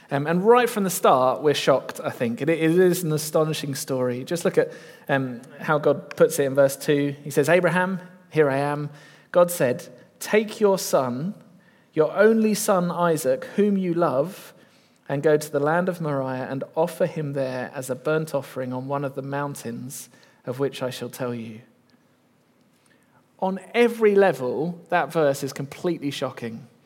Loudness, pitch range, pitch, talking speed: -23 LUFS, 135-180 Hz, 155 Hz, 175 wpm